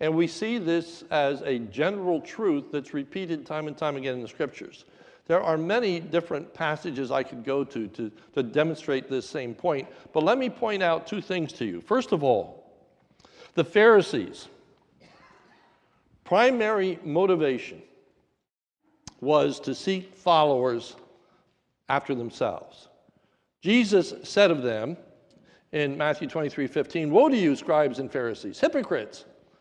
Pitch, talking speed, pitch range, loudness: 160 Hz, 140 wpm, 140-185 Hz, -26 LUFS